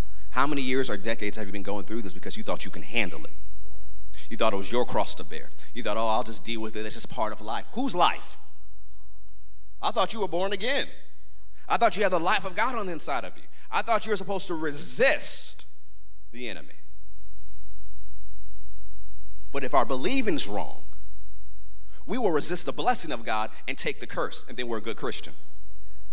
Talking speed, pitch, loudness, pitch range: 210 wpm, 90 Hz, -29 LUFS, 85-115 Hz